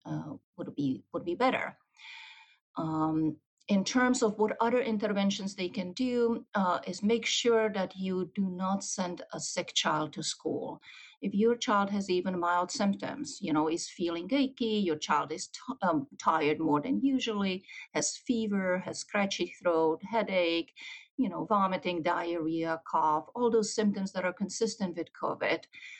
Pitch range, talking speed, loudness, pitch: 175-230 Hz, 160 wpm, -31 LUFS, 195 Hz